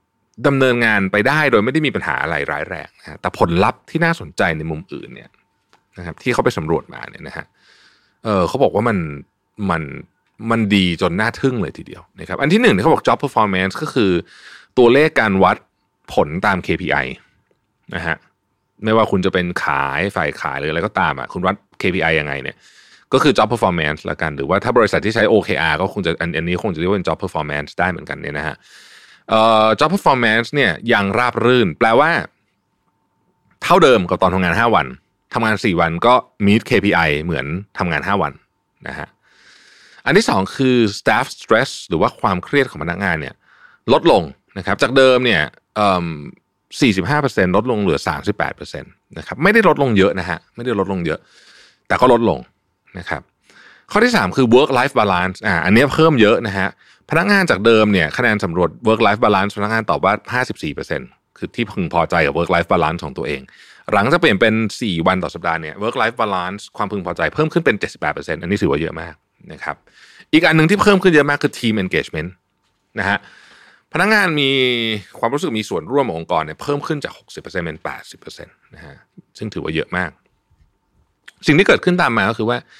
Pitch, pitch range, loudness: 110 Hz, 95-130 Hz, -16 LUFS